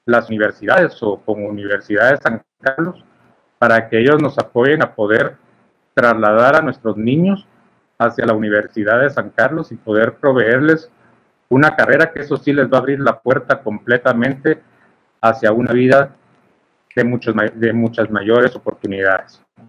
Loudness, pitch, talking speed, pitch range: -15 LUFS, 120 Hz, 150 wpm, 110-135 Hz